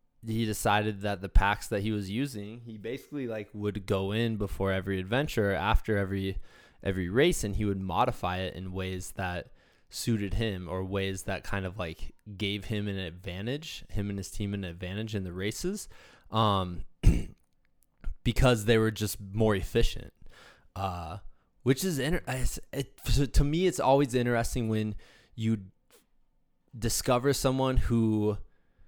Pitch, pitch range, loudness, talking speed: 105 Hz, 95-115 Hz, -30 LUFS, 155 wpm